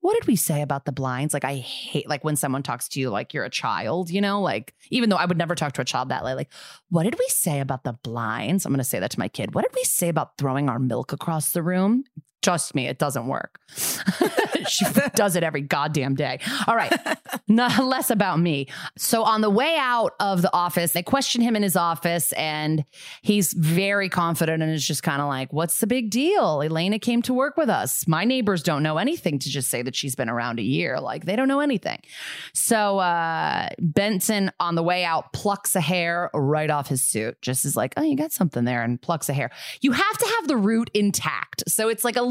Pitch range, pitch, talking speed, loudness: 145-215 Hz, 175 Hz, 240 wpm, -23 LUFS